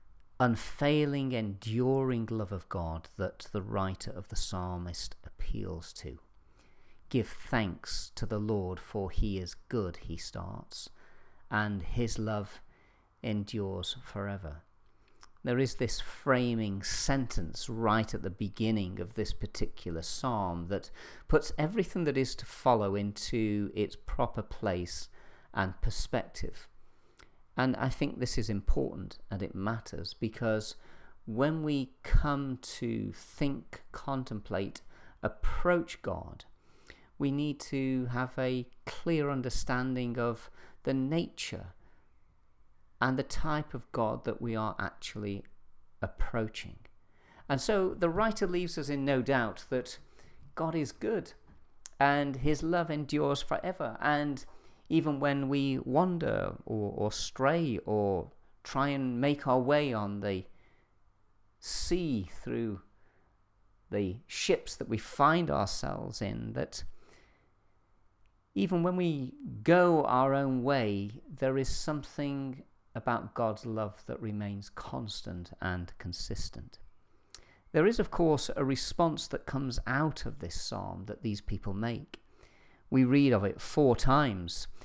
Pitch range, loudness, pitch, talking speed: 100-135 Hz, -33 LUFS, 110 Hz, 125 wpm